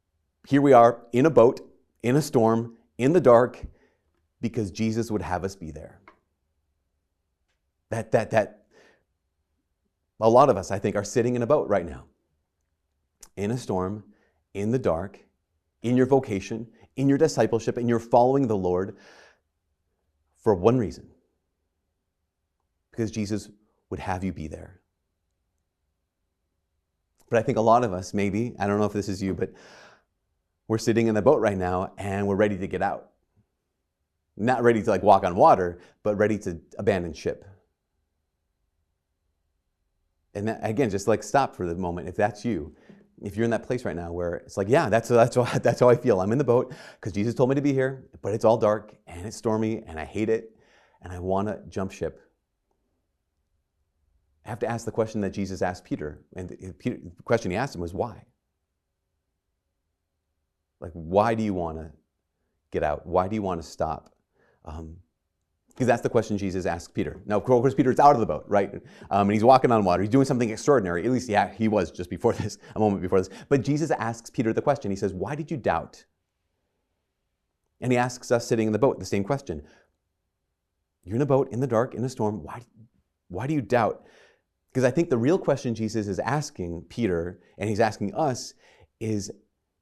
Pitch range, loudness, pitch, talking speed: 80-115 Hz, -25 LUFS, 95 Hz, 190 wpm